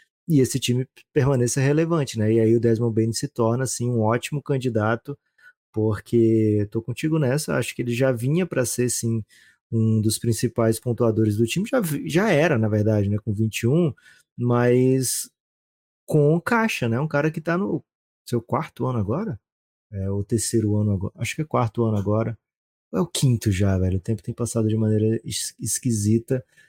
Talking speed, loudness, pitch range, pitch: 180 wpm, -23 LUFS, 110-135 Hz, 115 Hz